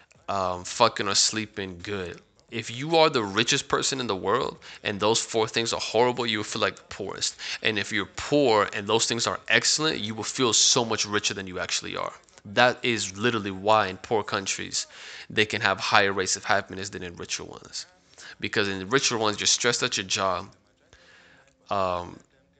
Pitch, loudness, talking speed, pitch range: 110 Hz, -25 LUFS, 195 wpm, 95-115 Hz